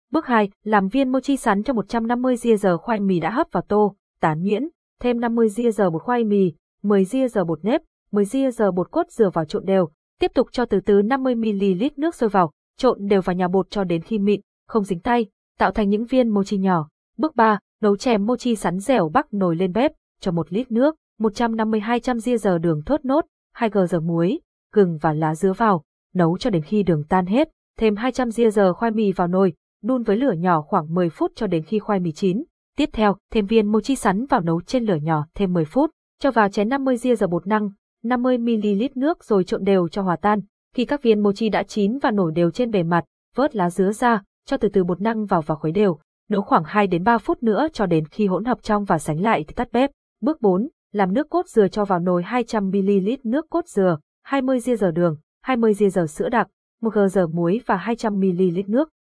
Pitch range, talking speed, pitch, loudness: 190-245 Hz, 225 wpm, 210 Hz, -21 LUFS